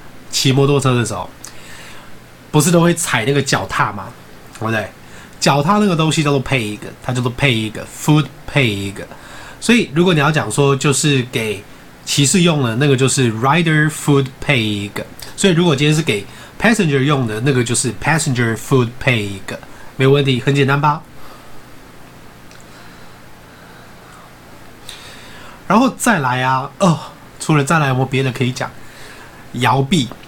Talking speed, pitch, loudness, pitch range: 275 characters per minute, 135 Hz, -15 LUFS, 115-150 Hz